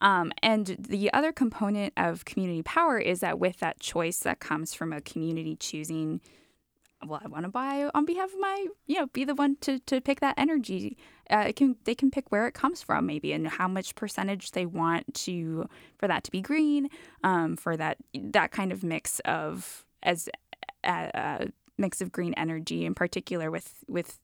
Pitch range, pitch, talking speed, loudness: 170-275 Hz, 205 Hz, 200 wpm, -29 LUFS